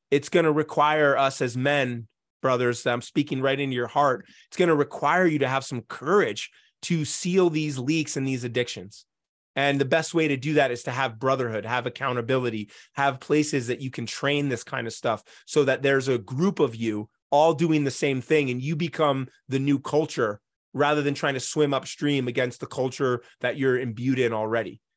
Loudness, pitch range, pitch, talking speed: -25 LUFS, 125-150 Hz, 135 Hz, 205 wpm